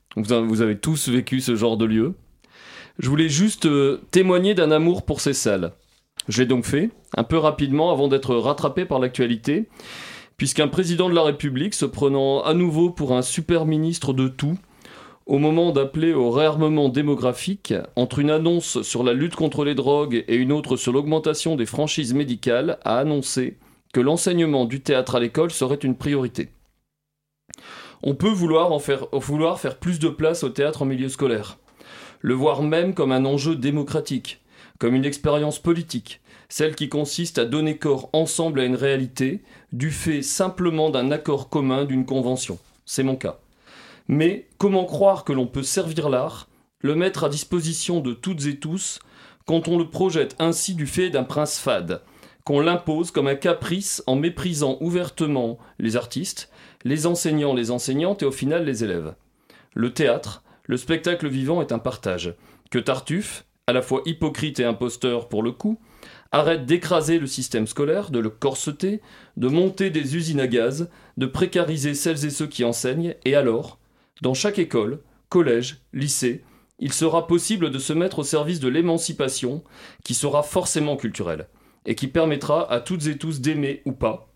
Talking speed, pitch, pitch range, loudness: 170 wpm, 145 Hz, 130-165 Hz, -22 LUFS